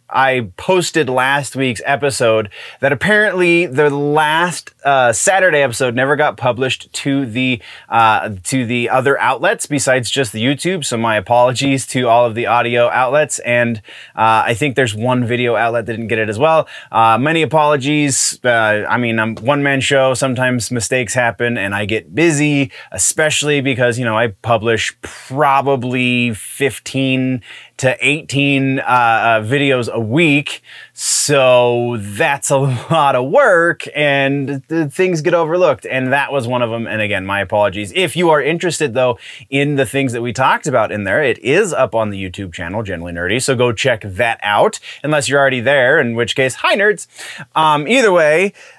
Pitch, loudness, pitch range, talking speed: 130 Hz, -14 LUFS, 120-145 Hz, 175 wpm